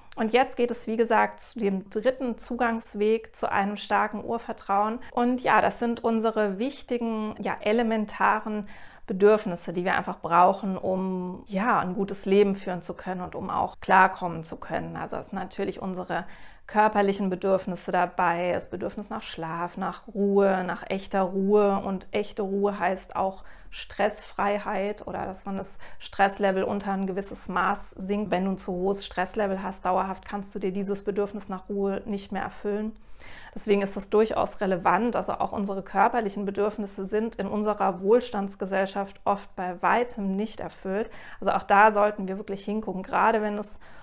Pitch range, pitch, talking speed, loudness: 190-215 Hz, 200 Hz, 165 wpm, -27 LUFS